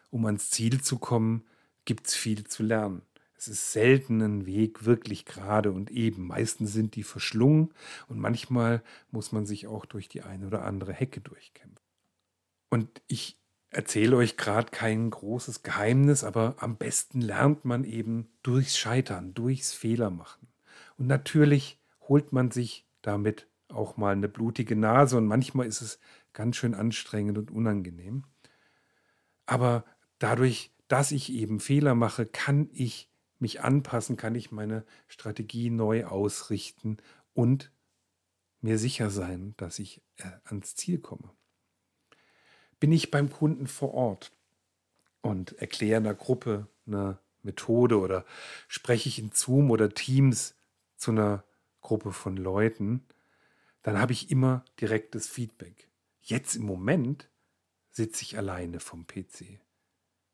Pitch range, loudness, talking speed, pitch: 105-125 Hz, -29 LUFS, 140 wpm, 115 Hz